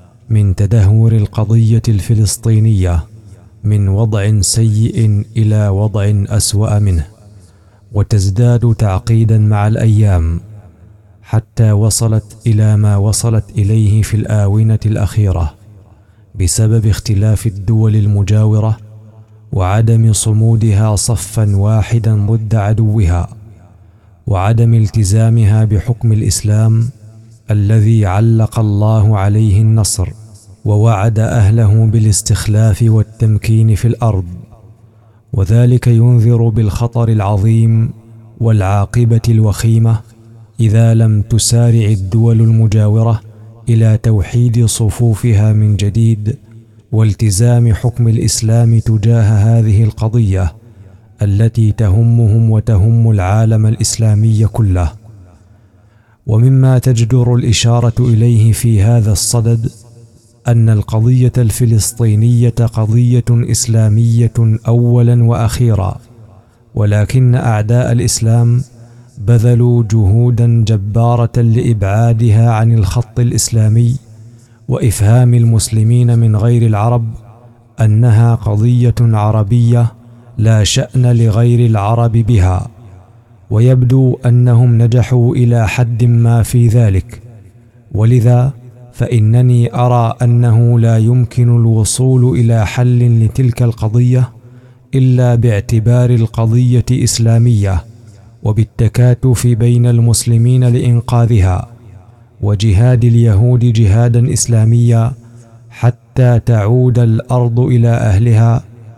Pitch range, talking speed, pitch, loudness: 110-120 Hz, 85 wpm, 115 Hz, -11 LUFS